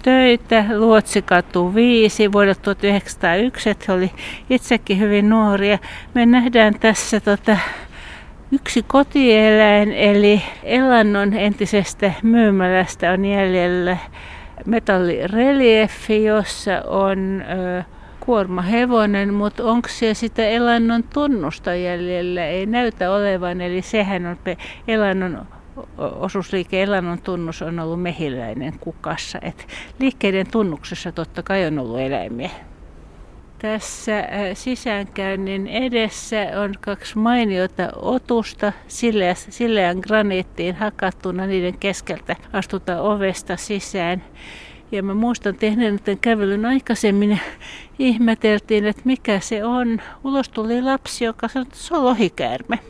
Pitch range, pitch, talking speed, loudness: 185-225 Hz, 205 Hz, 105 wpm, -18 LUFS